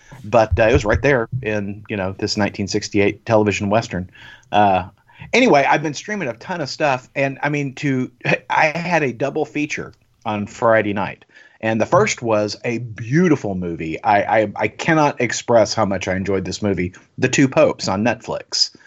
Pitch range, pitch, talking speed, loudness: 100-140 Hz, 115 Hz, 180 wpm, -19 LUFS